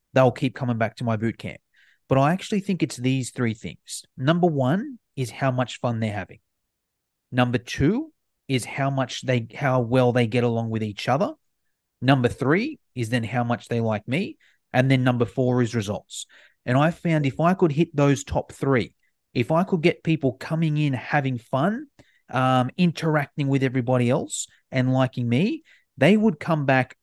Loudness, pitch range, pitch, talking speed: -23 LUFS, 120-155 Hz, 130 Hz, 185 wpm